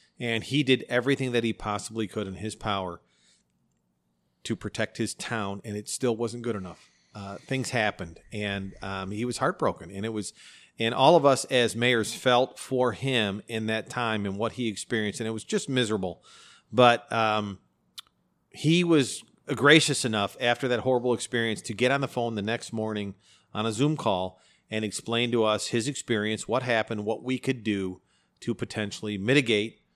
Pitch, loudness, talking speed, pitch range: 115 Hz, -27 LUFS, 180 wpm, 105-125 Hz